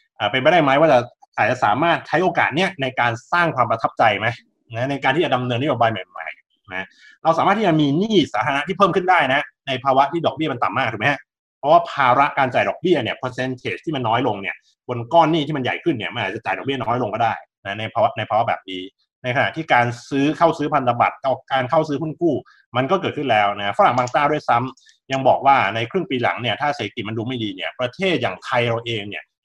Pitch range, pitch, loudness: 115-150 Hz, 130 Hz, -19 LUFS